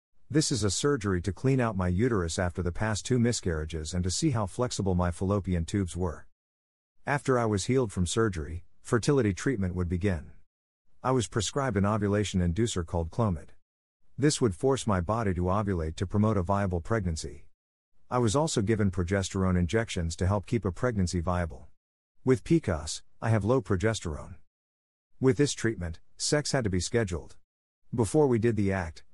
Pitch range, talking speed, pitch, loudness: 90-120 Hz, 175 wpm, 100 Hz, -29 LUFS